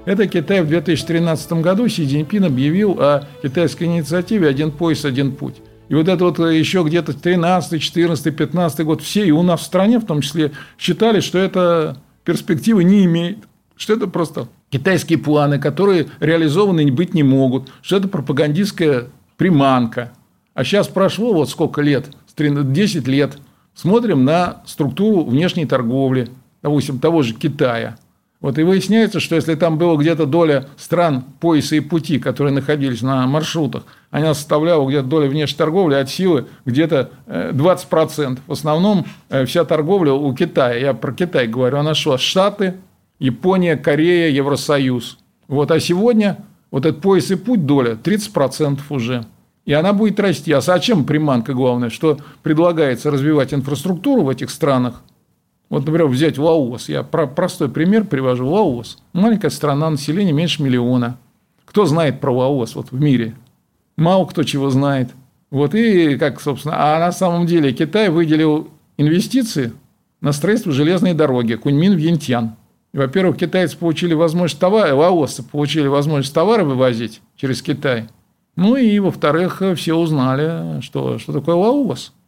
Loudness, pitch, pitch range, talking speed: -16 LUFS, 155 Hz, 140-175 Hz, 150 wpm